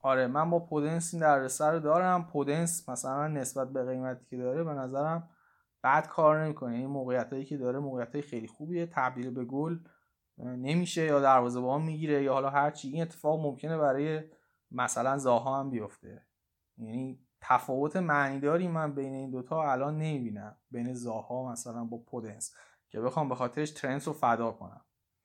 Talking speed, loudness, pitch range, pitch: 165 wpm, -31 LUFS, 125-155 Hz, 135 Hz